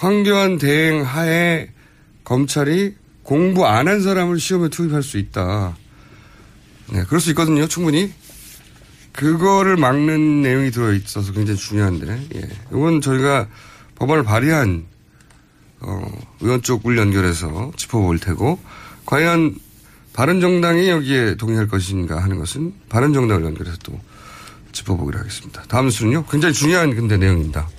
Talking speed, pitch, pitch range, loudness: 305 characters per minute, 130 Hz, 105-160 Hz, -18 LUFS